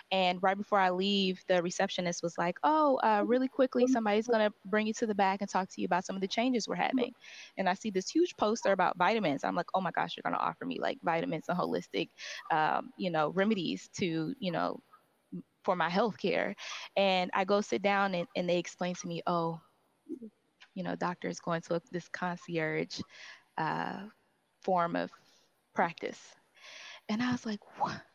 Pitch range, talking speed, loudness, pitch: 175-220 Hz, 200 wpm, -32 LUFS, 195 Hz